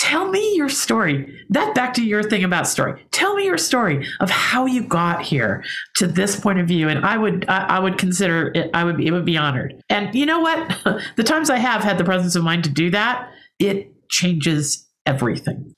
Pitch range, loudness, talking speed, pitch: 170-250 Hz, -19 LUFS, 220 wpm, 190 Hz